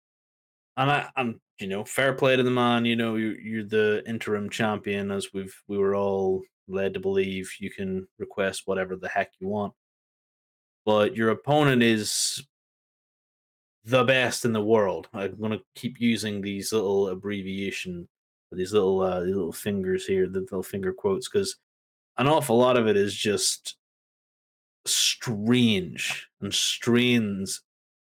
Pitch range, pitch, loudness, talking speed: 100-130 Hz, 110 Hz, -25 LUFS, 150 wpm